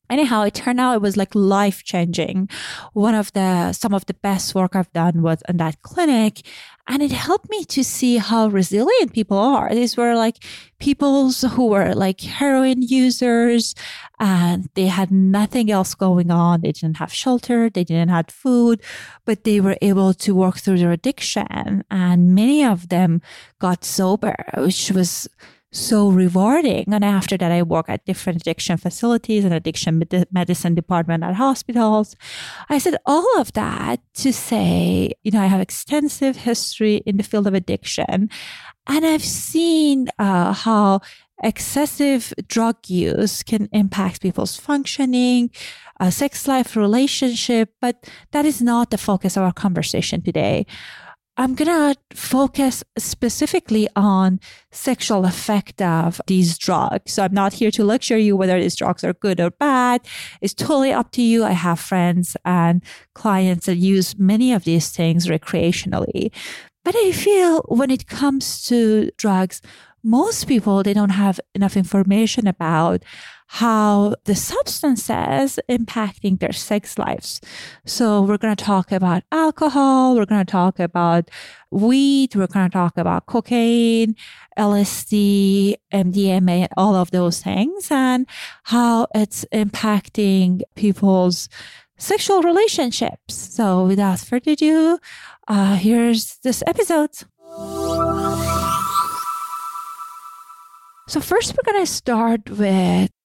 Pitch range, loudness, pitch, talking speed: 185-245 Hz, -18 LUFS, 205 Hz, 140 wpm